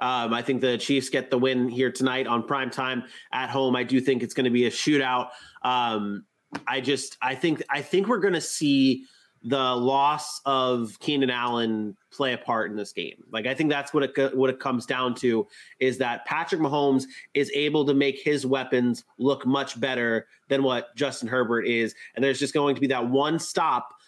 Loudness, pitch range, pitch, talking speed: -25 LUFS, 125-140 Hz, 130 Hz, 210 wpm